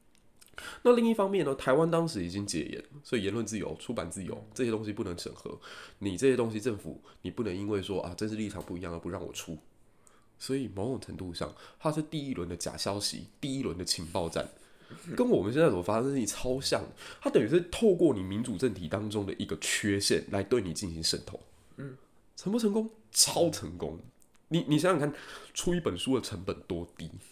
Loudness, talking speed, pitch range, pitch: -31 LUFS, 310 characters per minute, 95-145 Hz, 110 Hz